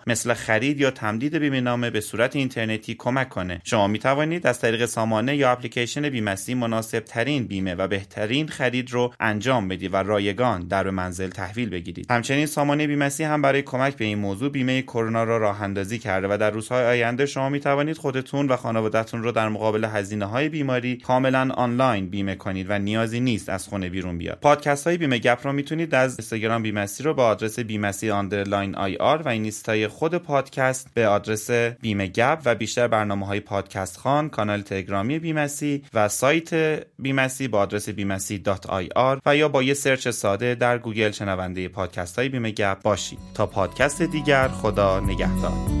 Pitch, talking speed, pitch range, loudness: 115 Hz, 175 wpm, 100-130 Hz, -23 LUFS